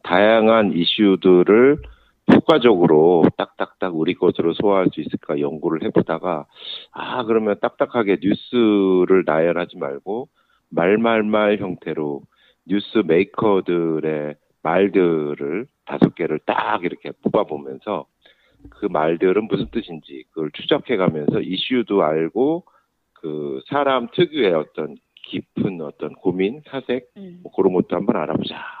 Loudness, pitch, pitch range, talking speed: -19 LUFS, 95 Hz, 80-115 Hz, 270 characters per minute